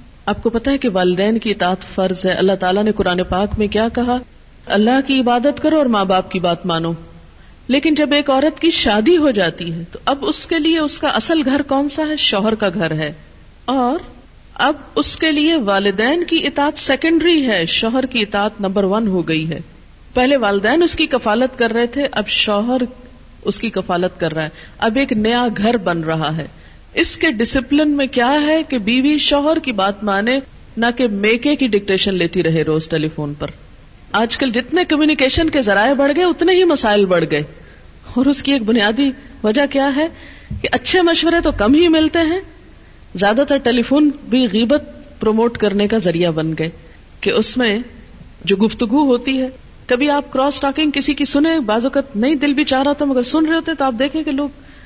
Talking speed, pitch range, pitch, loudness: 205 wpm, 200-290 Hz, 250 Hz, -15 LUFS